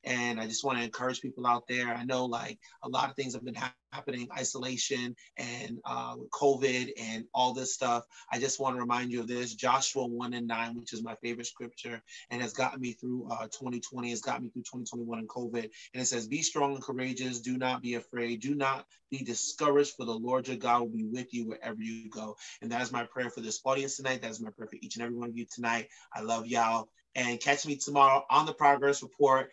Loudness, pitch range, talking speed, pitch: -32 LUFS, 120-130 Hz, 240 wpm, 125 Hz